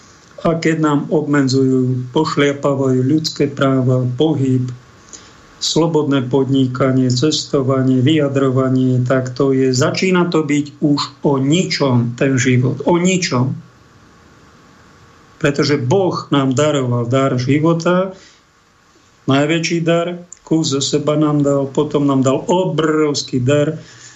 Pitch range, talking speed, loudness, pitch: 130-155 Hz, 105 wpm, -15 LUFS, 145 Hz